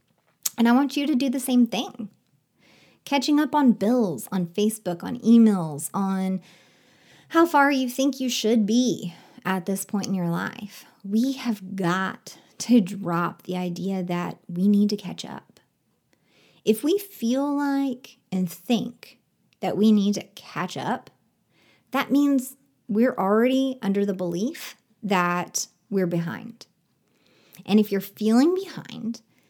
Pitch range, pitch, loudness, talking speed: 190-255 Hz, 215 Hz, -24 LUFS, 145 wpm